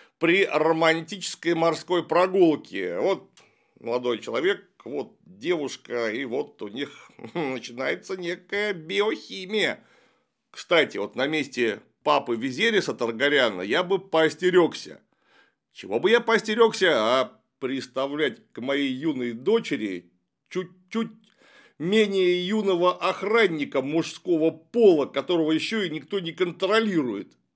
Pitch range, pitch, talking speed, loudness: 155-205 Hz, 180 Hz, 105 wpm, -24 LUFS